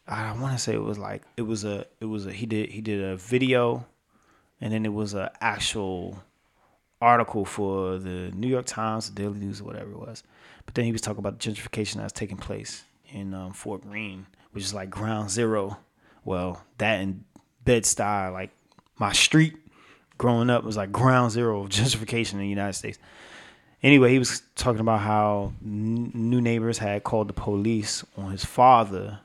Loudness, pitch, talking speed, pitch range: -25 LUFS, 105 Hz, 195 wpm, 100-115 Hz